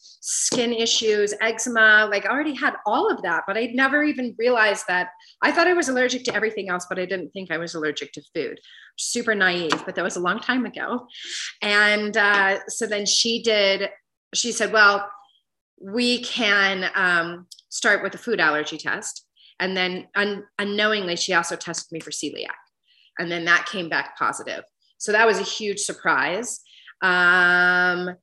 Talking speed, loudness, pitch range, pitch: 175 wpm, -21 LUFS, 180-225 Hz, 205 Hz